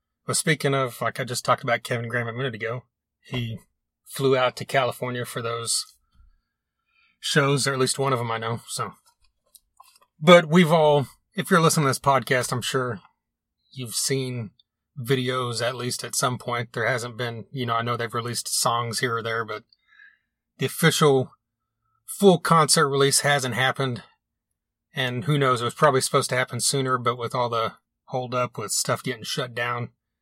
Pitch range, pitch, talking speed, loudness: 120-140 Hz, 125 Hz, 175 wpm, -23 LUFS